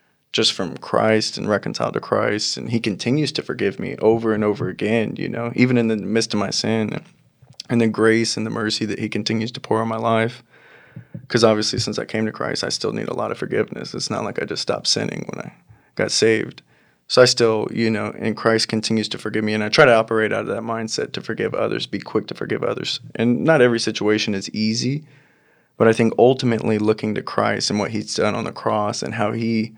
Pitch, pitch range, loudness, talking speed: 110 Hz, 110-115 Hz, -20 LUFS, 235 wpm